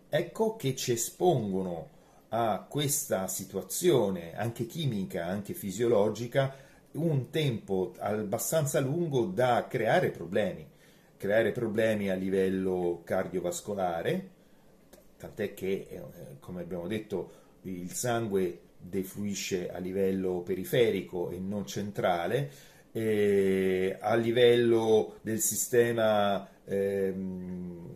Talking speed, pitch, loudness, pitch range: 95 wpm, 105 Hz, -30 LUFS, 95-120 Hz